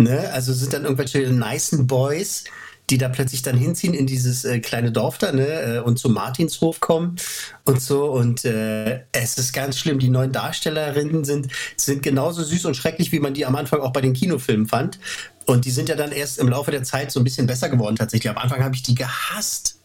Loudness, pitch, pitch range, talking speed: -21 LUFS, 135 Hz, 125-145 Hz, 220 wpm